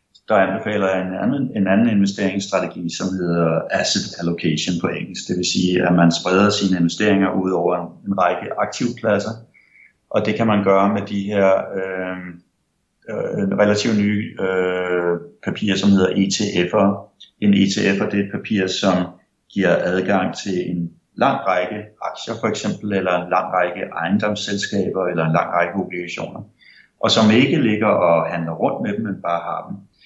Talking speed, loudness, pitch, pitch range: 165 wpm, -19 LUFS, 95 Hz, 90-100 Hz